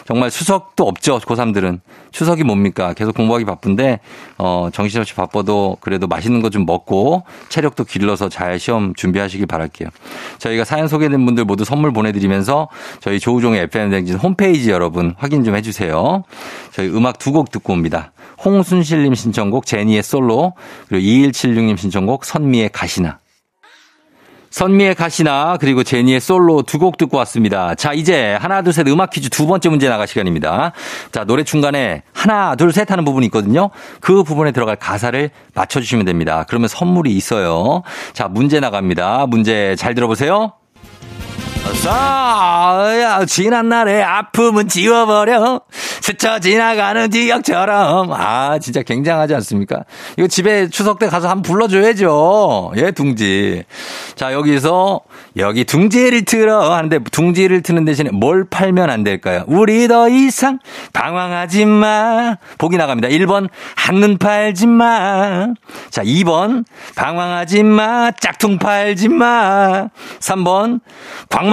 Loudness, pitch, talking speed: -14 LUFS, 155 Hz, 310 characters per minute